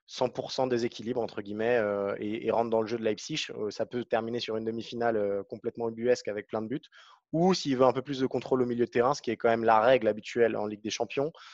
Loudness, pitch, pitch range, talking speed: -29 LUFS, 115 Hz, 110-125 Hz, 265 wpm